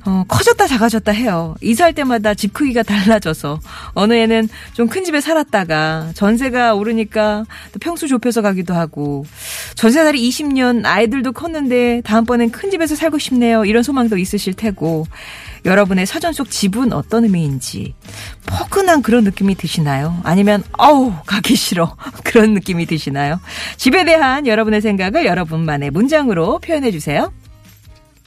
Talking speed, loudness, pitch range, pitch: 340 characters per minute, -15 LUFS, 170-250 Hz, 220 Hz